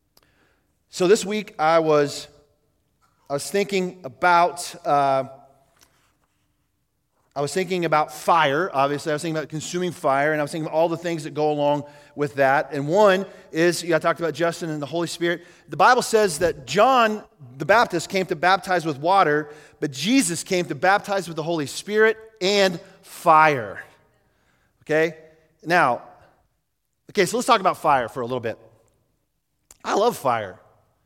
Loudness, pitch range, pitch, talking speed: -21 LUFS, 145-185 Hz, 160 Hz, 165 wpm